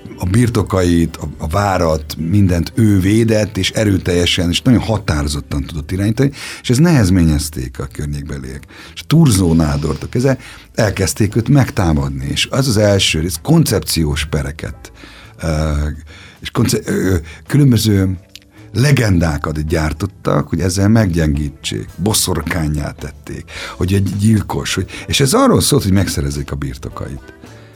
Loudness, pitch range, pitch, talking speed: -15 LUFS, 80-110 Hz, 95 Hz, 115 wpm